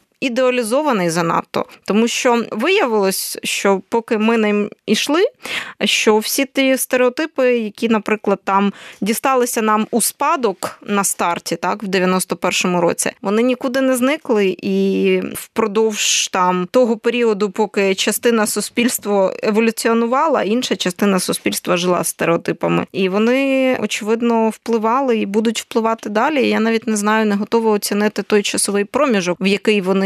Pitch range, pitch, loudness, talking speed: 200-240 Hz, 220 Hz, -17 LUFS, 135 wpm